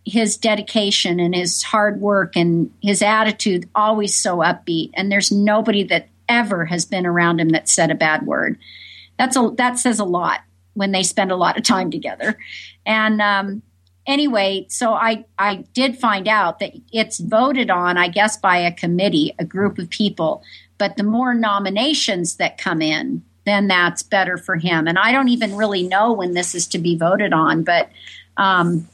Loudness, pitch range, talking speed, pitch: -18 LUFS, 175-220 Hz, 185 wpm, 195 Hz